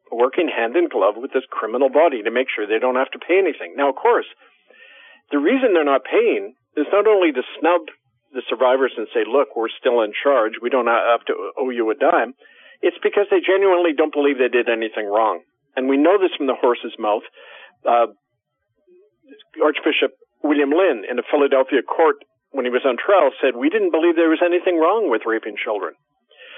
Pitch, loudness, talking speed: 195 Hz, -19 LUFS, 200 wpm